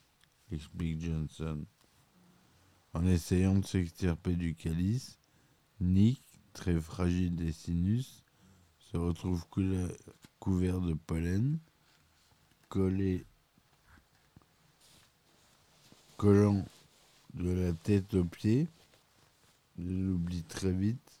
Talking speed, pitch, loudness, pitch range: 80 wpm, 90 Hz, -33 LUFS, 85-95 Hz